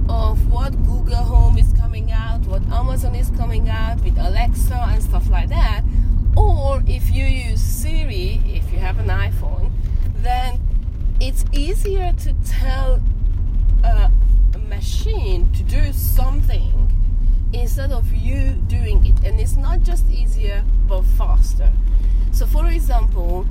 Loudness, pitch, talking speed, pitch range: -20 LUFS, 85 Hz, 135 wpm, 85-90 Hz